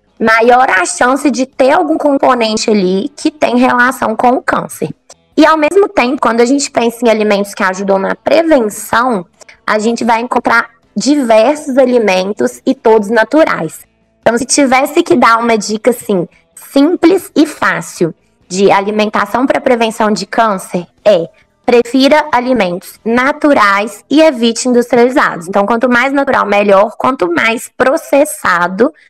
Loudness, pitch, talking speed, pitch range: -11 LUFS, 245 Hz, 140 wpm, 215-285 Hz